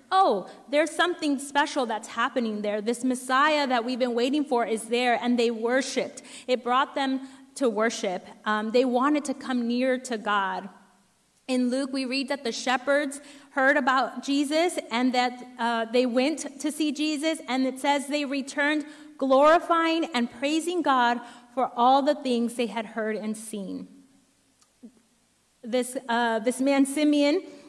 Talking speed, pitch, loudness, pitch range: 160 wpm, 260 Hz, -25 LUFS, 240-285 Hz